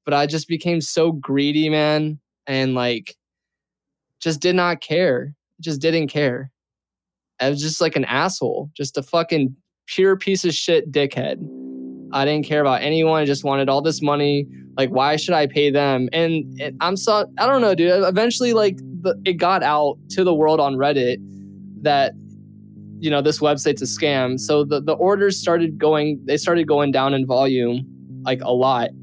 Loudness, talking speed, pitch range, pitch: -19 LUFS, 180 wpm, 135-165 Hz, 150 Hz